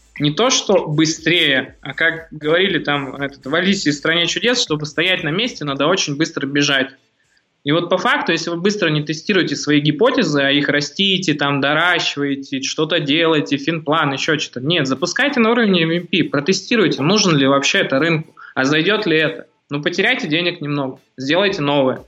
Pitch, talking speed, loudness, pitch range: 155 Hz, 175 wpm, -16 LUFS, 145-175 Hz